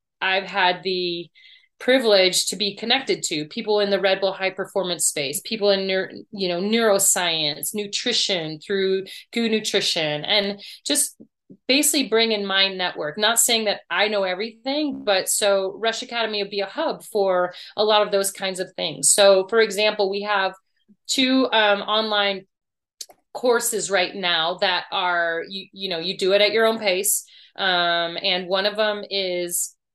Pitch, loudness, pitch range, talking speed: 195 Hz, -21 LUFS, 185-215 Hz, 165 wpm